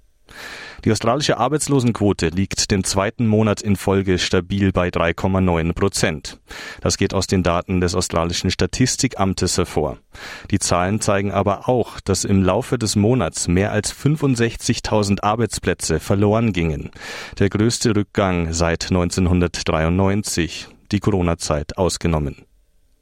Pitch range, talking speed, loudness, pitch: 90-105 Hz, 120 wpm, -19 LUFS, 95 Hz